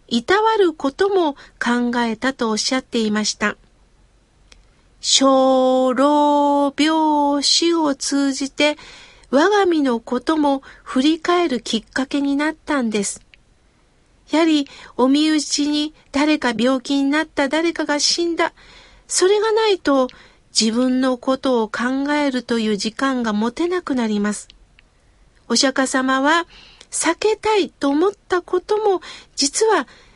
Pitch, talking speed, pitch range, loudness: 285 Hz, 200 characters per minute, 255-325 Hz, -18 LUFS